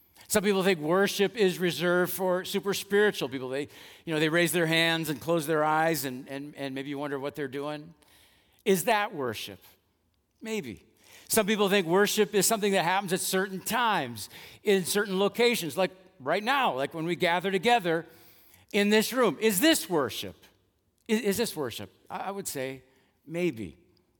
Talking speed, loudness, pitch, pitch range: 175 wpm, -27 LUFS, 175 Hz, 145-200 Hz